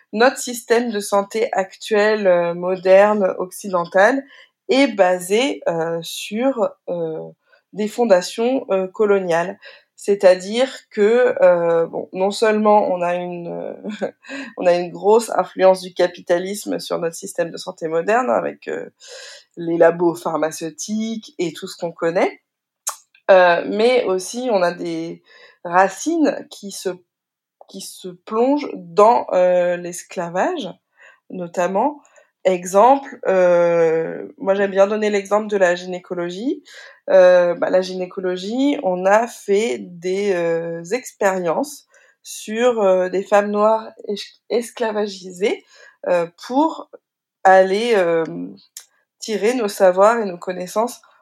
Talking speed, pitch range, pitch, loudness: 120 wpm, 180-230 Hz, 195 Hz, -18 LUFS